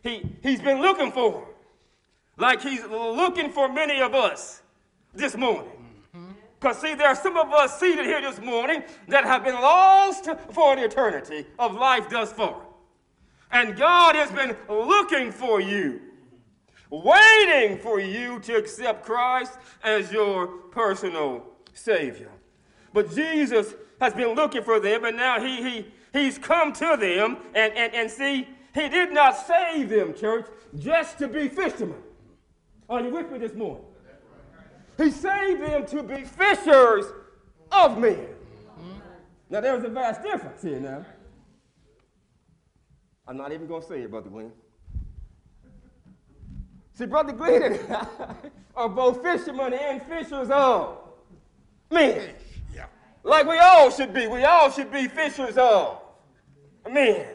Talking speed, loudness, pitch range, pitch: 140 wpm, -21 LUFS, 225-315 Hz, 270 Hz